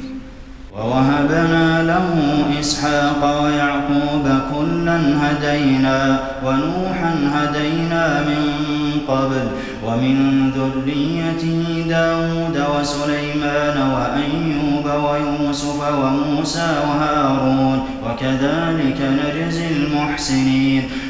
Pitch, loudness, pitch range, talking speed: 145 Hz, -18 LUFS, 135-150 Hz, 60 wpm